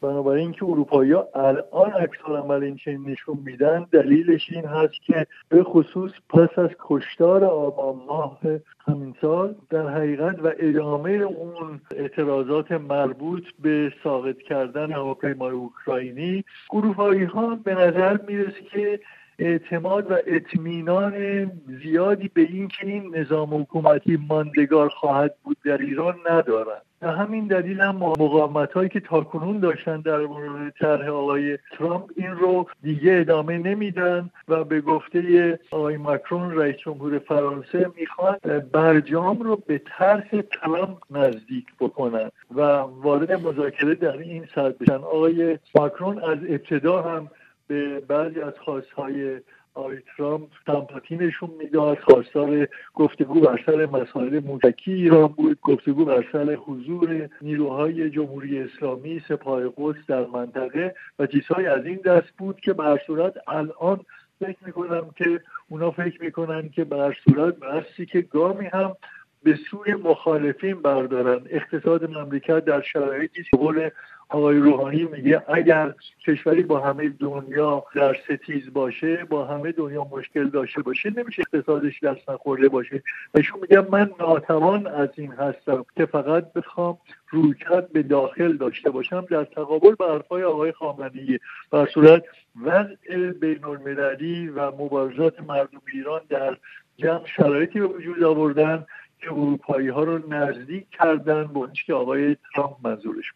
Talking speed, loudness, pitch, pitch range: 135 wpm, -22 LUFS, 155 Hz, 145-175 Hz